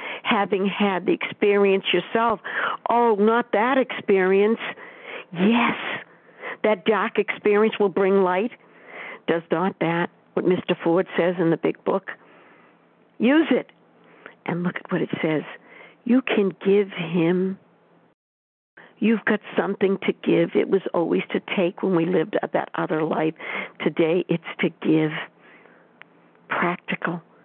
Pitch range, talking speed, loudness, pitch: 175-215 Hz, 130 wpm, -22 LUFS, 195 Hz